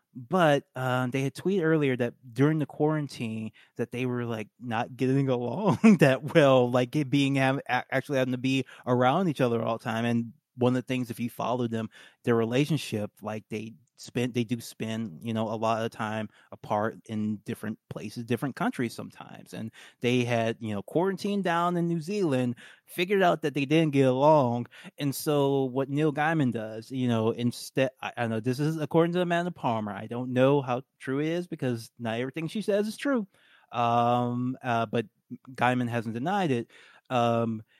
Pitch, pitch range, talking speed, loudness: 125 Hz, 115-150 Hz, 190 wpm, -28 LUFS